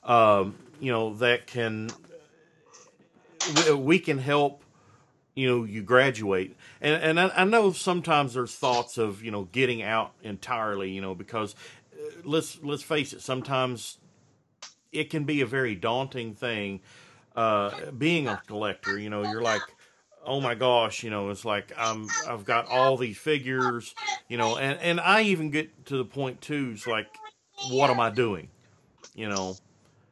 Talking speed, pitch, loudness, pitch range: 160 wpm, 125 Hz, -27 LUFS, 110-145 Hz